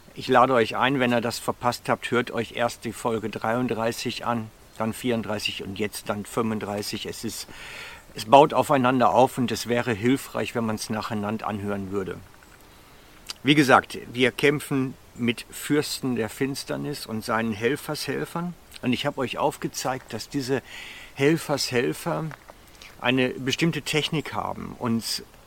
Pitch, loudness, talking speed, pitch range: 120 Hz, -25 LUFS, 145 wpm, 110-135 Hz